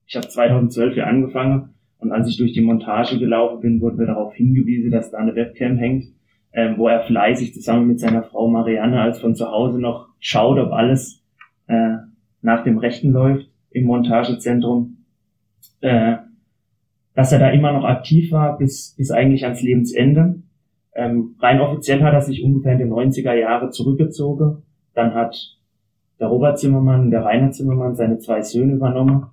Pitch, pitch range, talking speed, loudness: 120 Hz, 115-135 Hz, 170 wpm, -17 LUFS